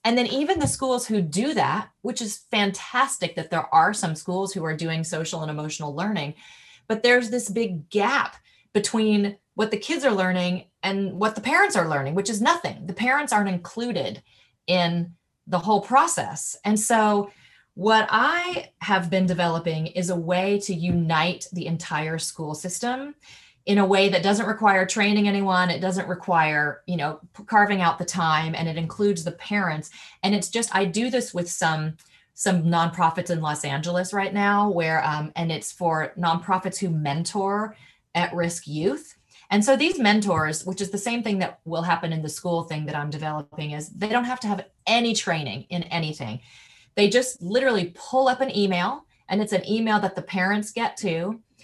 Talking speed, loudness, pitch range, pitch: 185 wpm, -24 LUFS, 165-210 Hz, 185 Hz